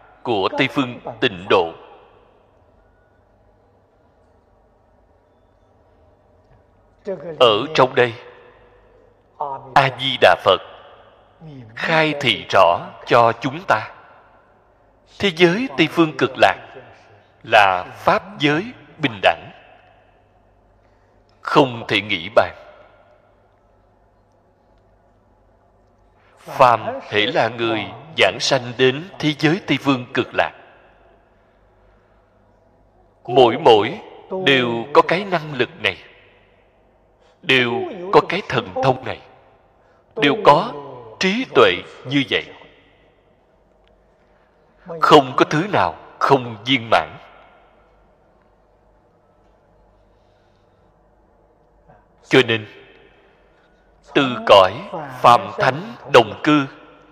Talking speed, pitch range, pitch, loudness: 85 wpm, 100-145 Hz, 120 Hz, -17 LUFS